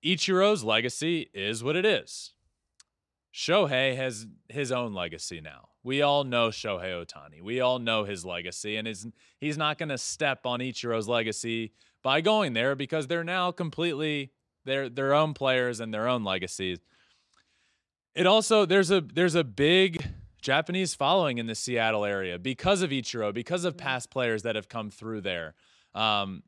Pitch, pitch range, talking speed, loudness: 125 Hz, 110-155 Hz, 165 wpm, -27 LUFS